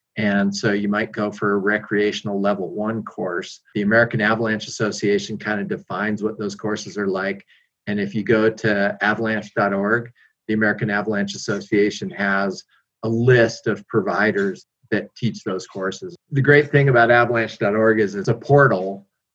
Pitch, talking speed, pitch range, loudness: 105 Hz, 160 wpm, 100-115 Hz, -20 LUFS